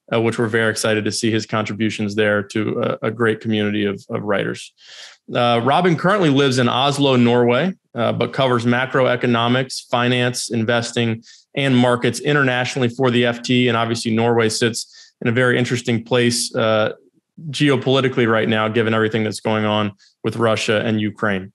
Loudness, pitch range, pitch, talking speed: -18 LUFS, 110-125 Hz, 120 Hz, 165 wpm